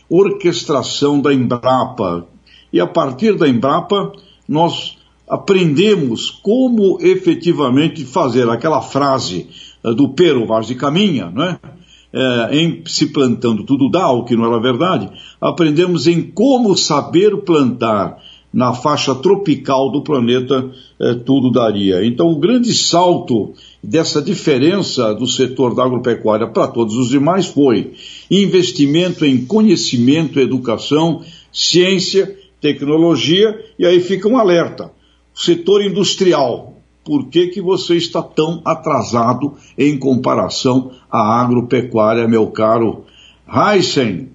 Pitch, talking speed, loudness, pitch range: 150 Hz, 120 wpm, -14 LUFS, 125-180 Hz